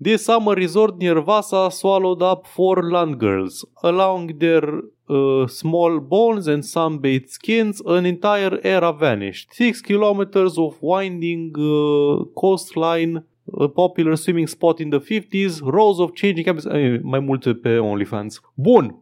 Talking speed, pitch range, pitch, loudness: 145 wpm, 150-195 Hz, 170 Hz, -19 LUFS